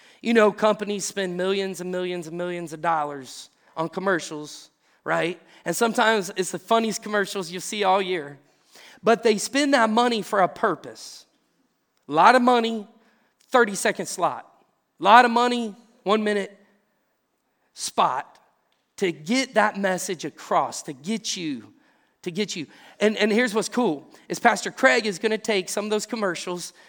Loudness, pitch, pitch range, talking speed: -23 LUFS, 205 Hz, 180-230 Hz, 165 wpm